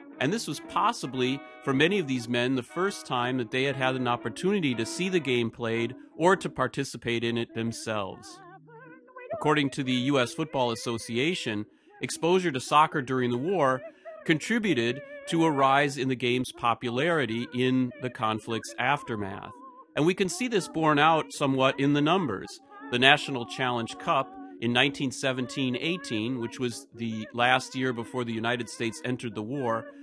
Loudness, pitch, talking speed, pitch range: -27 LUFS, 130 Hz, 165 wpm, 120-155 Hz